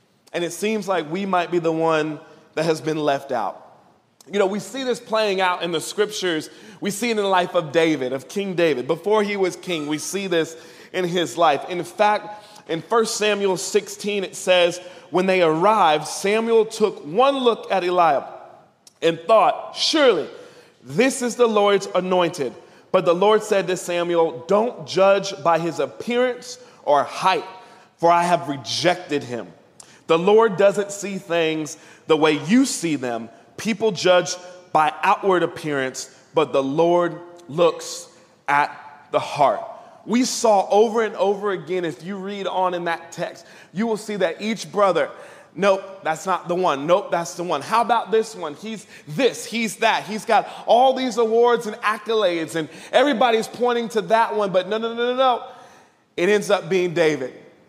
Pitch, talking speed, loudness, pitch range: 190 Hz, 175 wpm, -21 LUFS, 170-220 Hz